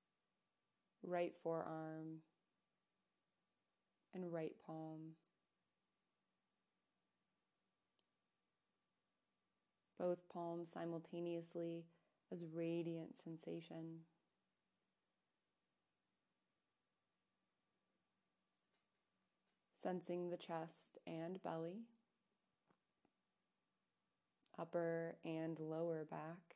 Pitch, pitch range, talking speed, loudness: 165 Hz, 160-170 Hz, 45 wpm, -49 LUFS